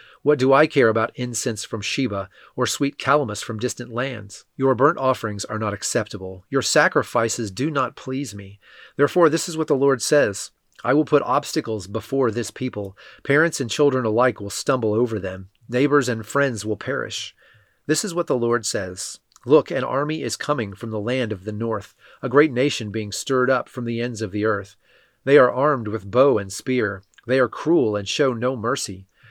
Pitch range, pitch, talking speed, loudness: 110-140 Hz, 120 Hz, 195 wpm, -21 LUFS